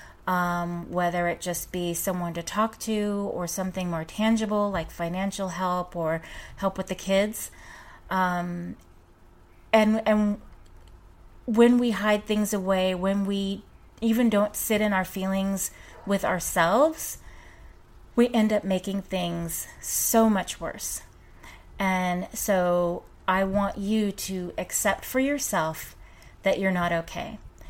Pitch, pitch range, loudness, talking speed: 190 Hz, 175-210 Hz, -26 LUFS, 130 wpm